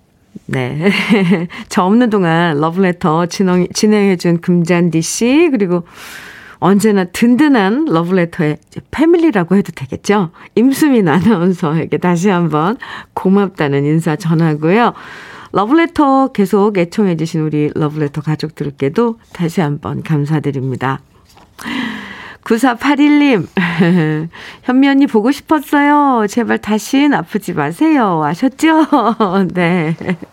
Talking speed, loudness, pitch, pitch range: 240 characters per minute, -13 LUFS, 190 Hz, 165-235 Hz